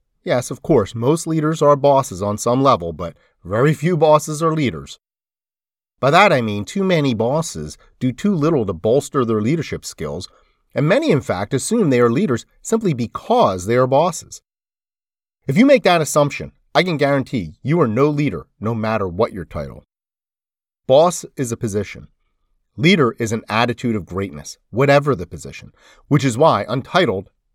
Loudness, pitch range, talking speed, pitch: -18 LUFS, 105-150 Hz, 170 wpm, 125 Hz